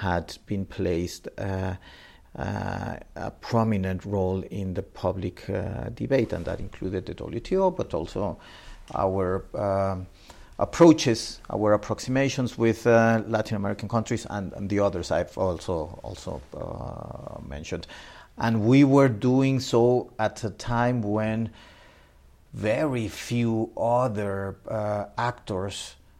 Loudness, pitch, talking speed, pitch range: -26 LUFS, 105 Hz, 120 wpm, 95-115 Hz